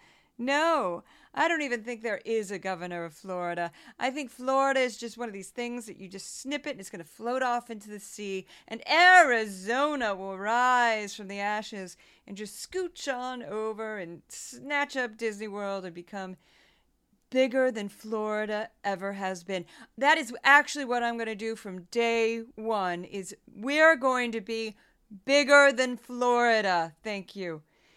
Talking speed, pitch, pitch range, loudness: 170 wpm, 225 Hz, 200-255 Hz, -27 LUFS